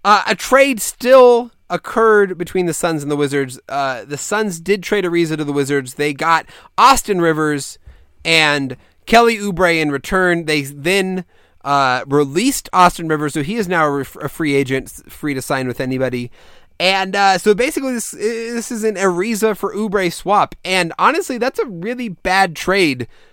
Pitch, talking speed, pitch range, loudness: 180 Hz, 170 wpm, 145-215 Hz, -16 LUFS